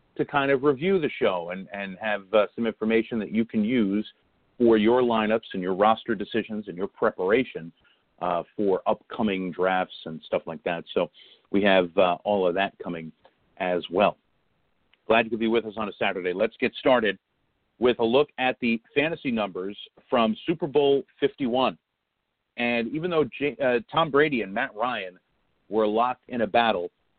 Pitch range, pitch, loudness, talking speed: 100-130 Hz, 115 Hz, -25 LUFS, 180 wpm